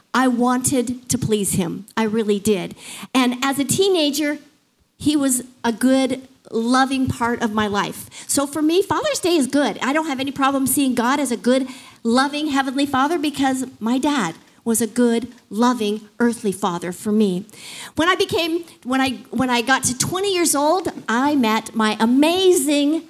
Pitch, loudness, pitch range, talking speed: 260 Hz, -19 LUFS, 230-285 Hz, 175 wpm